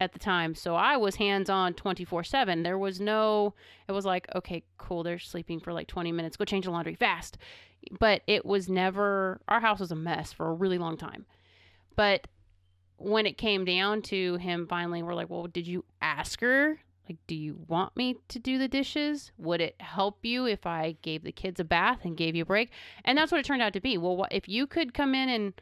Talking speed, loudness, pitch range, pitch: 230 wpm, -29 LUFS, 170-210 Hz, 185 Hz